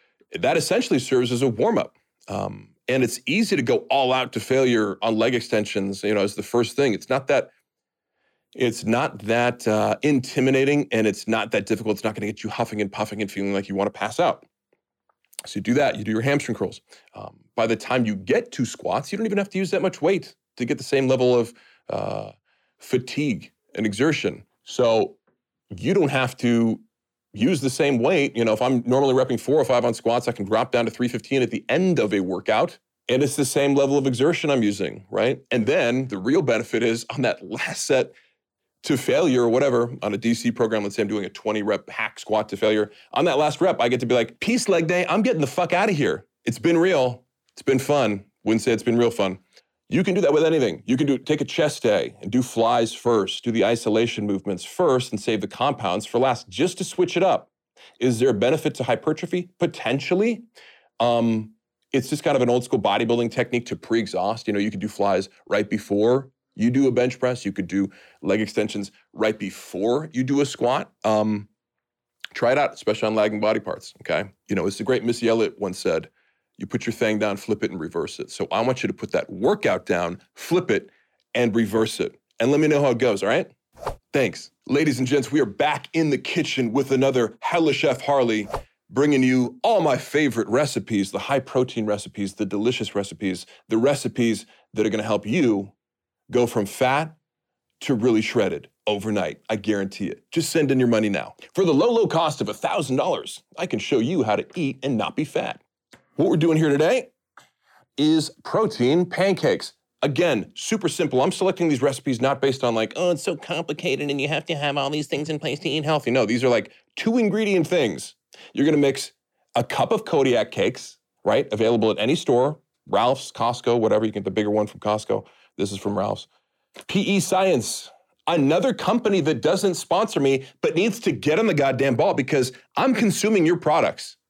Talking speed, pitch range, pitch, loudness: 215 wpm, 110-150 Hz, 125 Hz, -22 LUFS